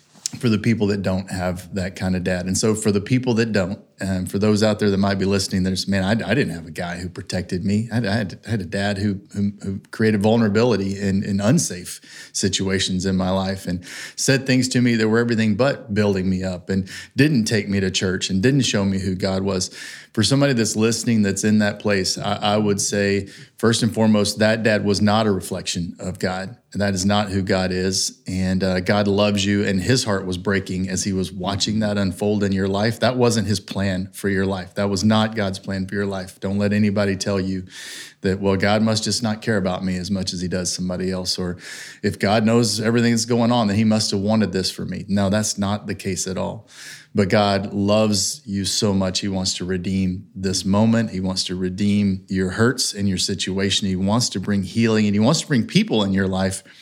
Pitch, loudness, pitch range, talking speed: 100 Hz, -20 LUFS, 95-110 Hz, 235 wpm